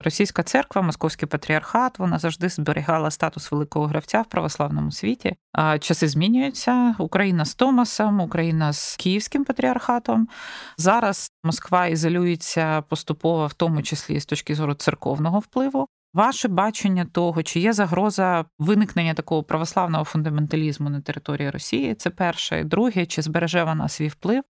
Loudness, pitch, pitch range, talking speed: -22 LUFS, 170 Hz, 155-205 Hz, 140 wpm